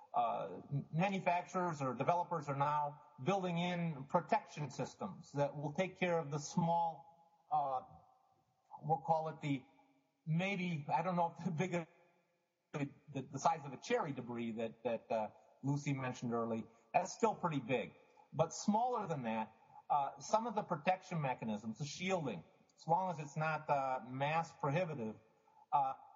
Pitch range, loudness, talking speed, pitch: 140-180 Hz, -39 LUFS, 155 wpm, 165 Hz